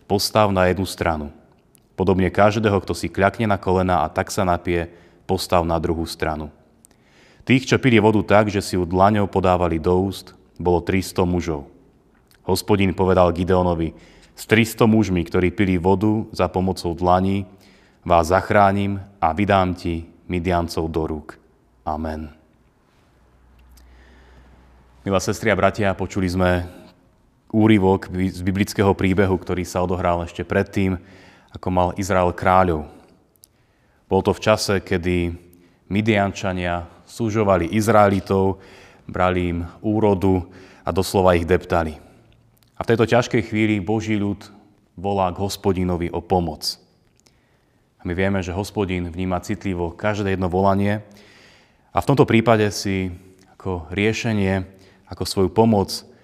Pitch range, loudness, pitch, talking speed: 90-100 Hz, -20 LUFS, 95 Hz, 130 wpm